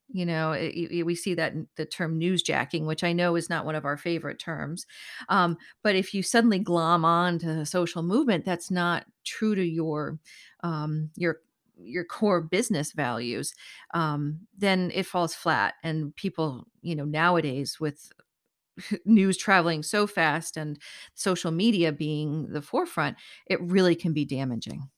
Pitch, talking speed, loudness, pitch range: 170 Hz, 165 wpm, -27 LUFS, 155-185 Hz